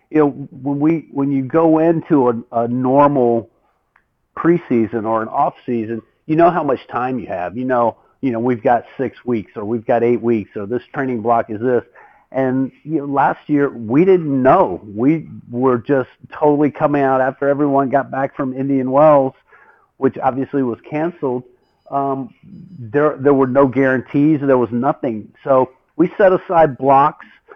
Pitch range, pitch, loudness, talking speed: 120-145 Hz, 135 Hz, -17 LUFS, 175 wpm